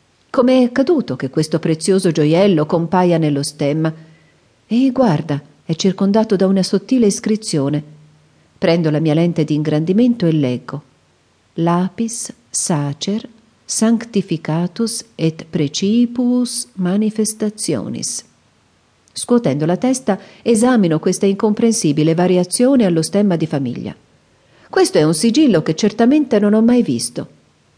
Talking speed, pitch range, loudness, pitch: 115 wpm, 160-230 Hz, -16 LUFS, 190 Hz